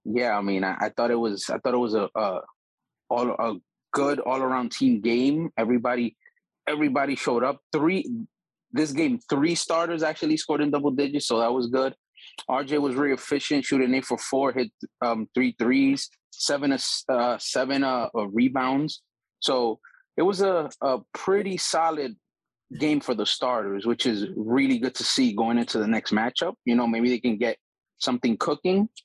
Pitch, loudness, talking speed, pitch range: 130 Hz, -25 LUFS, 175 wpm, 120-155 Hz